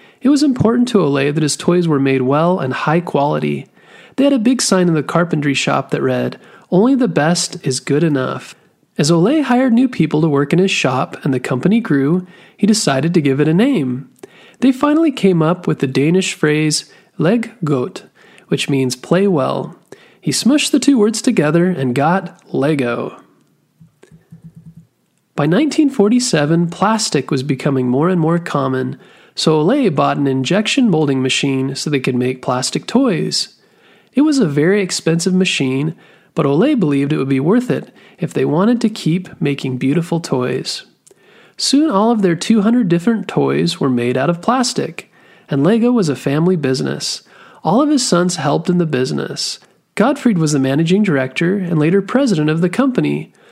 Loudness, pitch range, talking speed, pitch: -15 LUFS, 140-215 Hz, 175 wpm, 170 Hz